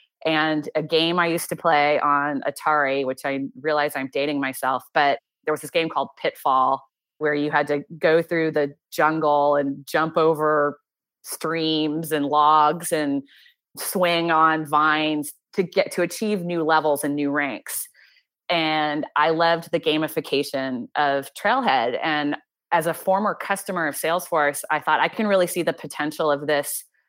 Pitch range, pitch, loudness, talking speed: 145-165 Hz, 155 Hz, -22 LUFS, 160 wpm